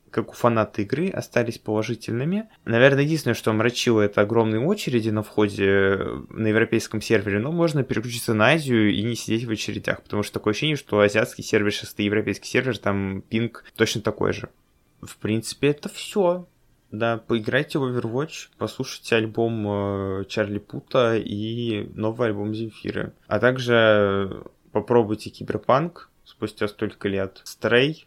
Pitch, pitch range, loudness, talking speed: 110 Hz, 105-120 Hz, -23 LUFS, 145 wpm